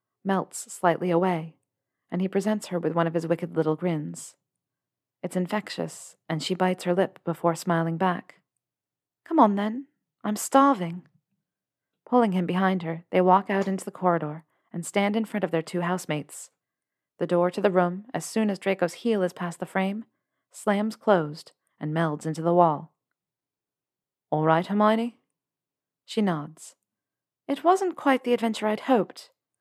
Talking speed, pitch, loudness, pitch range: 160 wpm, 185 Hz, -26 LUFS, 170-210 Hz